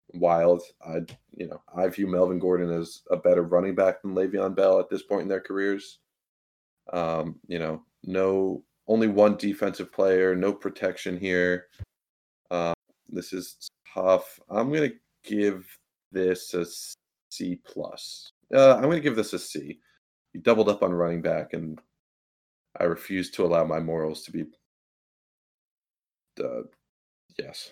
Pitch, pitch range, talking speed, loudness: 90 Hz, 85-100 Hz, 150 wpm, -26 LUFS